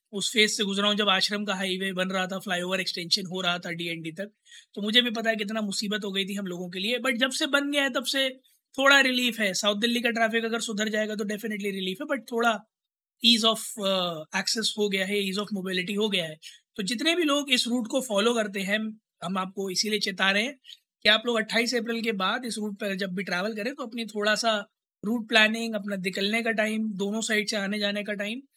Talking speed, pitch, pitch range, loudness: 245 wpm, 215 Hz, 195-235 Hz, -26 LUFS